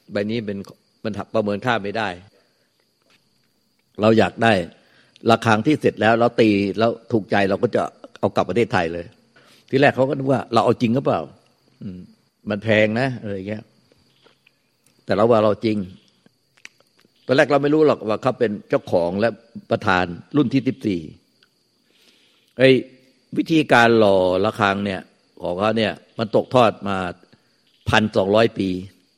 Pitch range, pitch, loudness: 100-120 Hz, 110 Hz, -19 LUFS